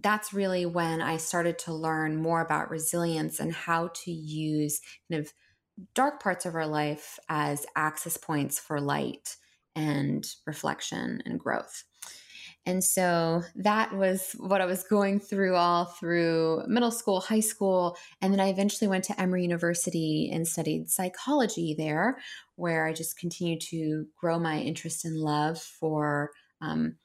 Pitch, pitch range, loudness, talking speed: 170 Hz, 155-190 Hz, -29 LUFS, 155 wpm